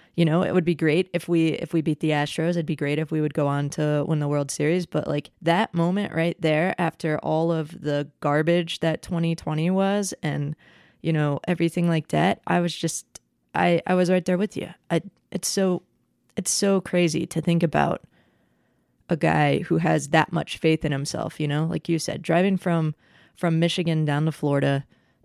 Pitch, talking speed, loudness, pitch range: 165 Hz, 205 wpm, -24 LUFS, 150-175 Hz